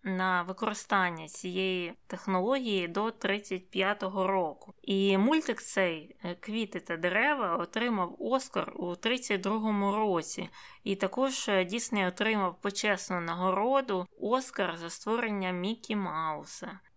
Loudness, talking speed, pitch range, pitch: -31 LUFS, 105 wpm, 185-220 Hz, 195 Hz